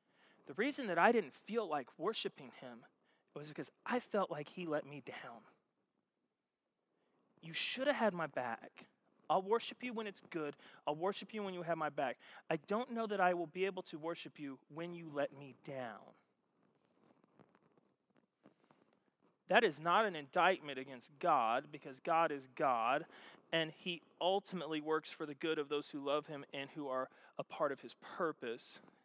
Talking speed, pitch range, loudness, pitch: 175 wpm, 150-195 Hz, -39 LUFS, 165 Hz